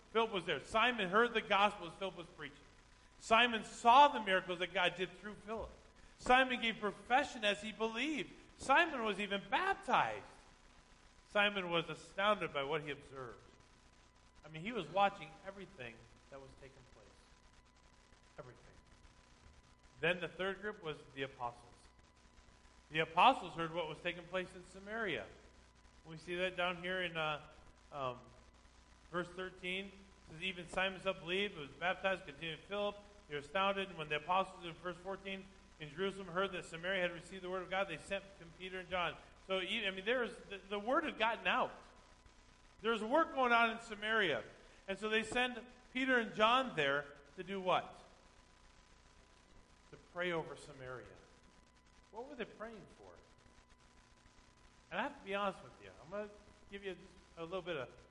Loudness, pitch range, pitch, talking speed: -37 LUFS, 160-205 Hz, 185 Hz, 170 wpm